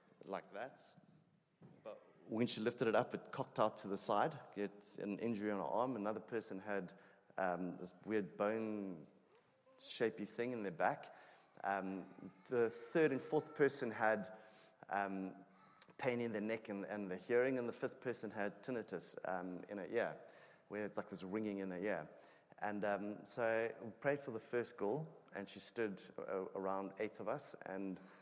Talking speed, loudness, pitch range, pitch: 175 wpm, -42 LUFS, 95-115 Hz, 105 Hz